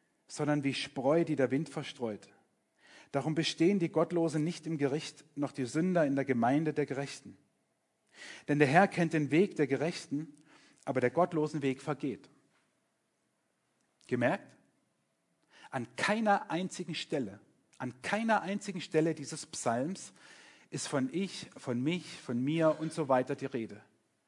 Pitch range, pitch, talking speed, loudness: 135-165 Hz, 150 Hz, 145 wpm, -33 LUFS